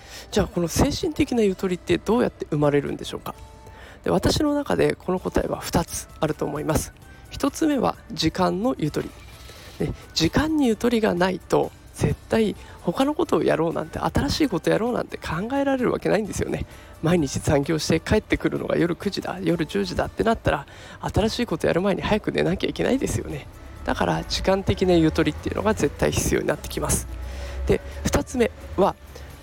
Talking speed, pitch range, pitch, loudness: 370 characters per minute, 155-240 Hz, 185 Hz, -24 LUFS